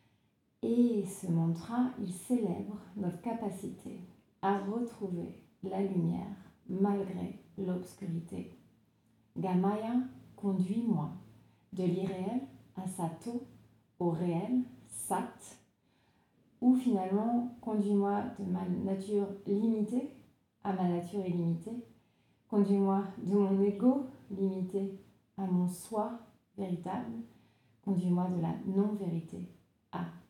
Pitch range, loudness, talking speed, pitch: 180-220 Hz, -34 LUFS, 95 wpm, 195 Hz